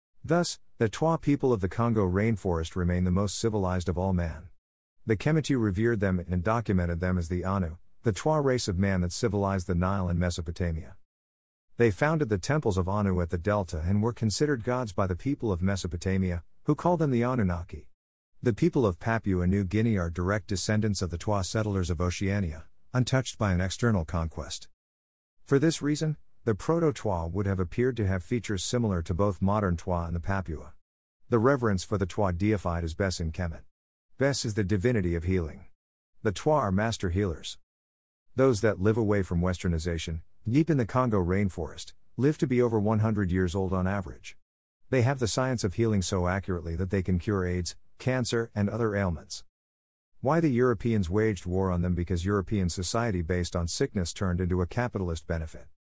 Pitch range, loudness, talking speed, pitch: 90-115 Hz, -28 LUFS, 185 wpm, 95 Hz